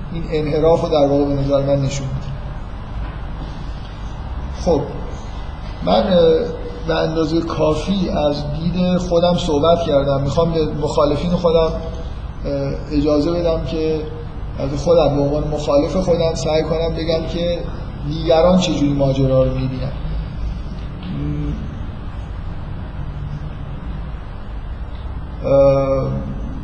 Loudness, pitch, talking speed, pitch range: -18 LUFS, 145 Hz, 90 wpm, 110-165 Hz